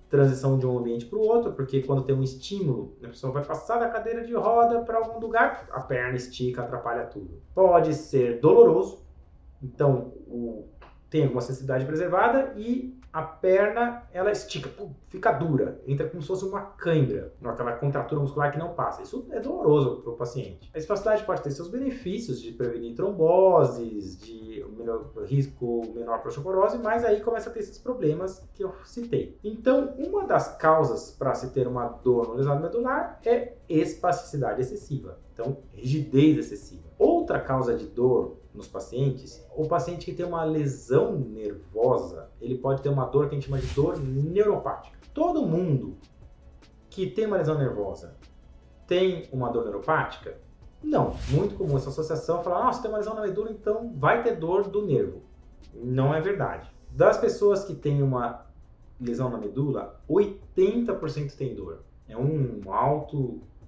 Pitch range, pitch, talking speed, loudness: 125-200 Hz, 145 Hz, 170 wpm, -26 LUFS